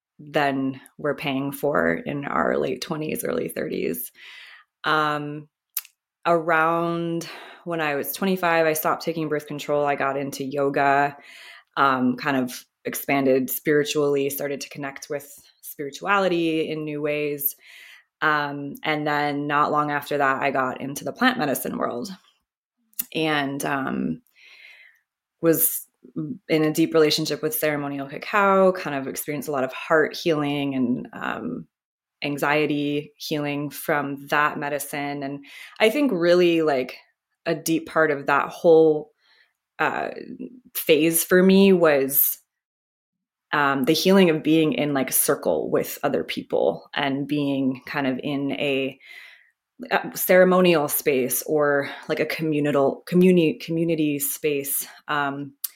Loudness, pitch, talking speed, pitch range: -22 LUFS, 150 Hz, 130 wpm, 140-160 Hz